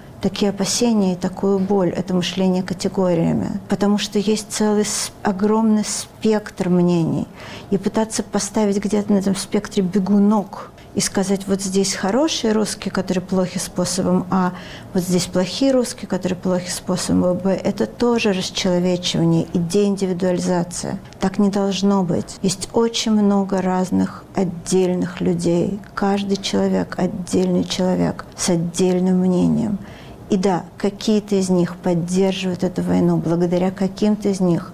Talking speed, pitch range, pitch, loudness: 130 wpm, 180-205 Hz, 190 Hz, -19 LUFS